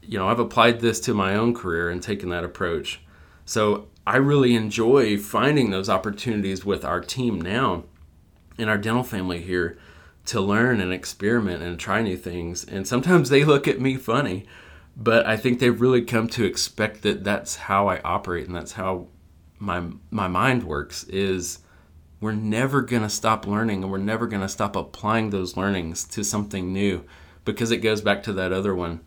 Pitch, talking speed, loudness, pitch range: 100 Hz, 190 wpm, -23 LUFS, 90-115 Hz